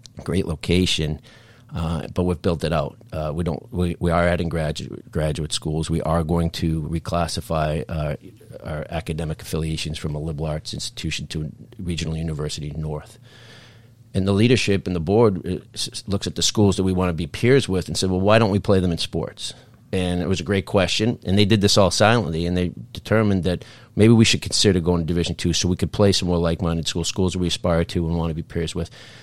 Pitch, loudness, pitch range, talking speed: 90 Hz, -22 LUFS, 80-100 Hz, 220 wpm